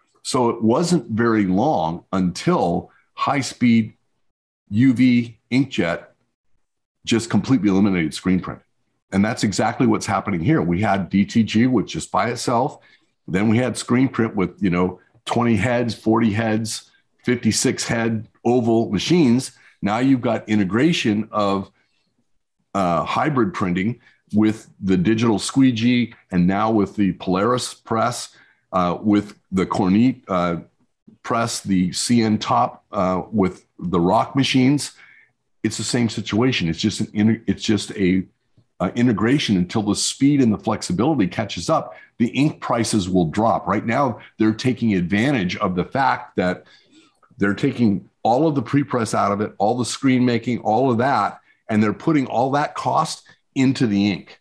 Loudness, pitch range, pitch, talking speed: -20 LUFS, 100-125 Hz, 110 Hz, 150 wpm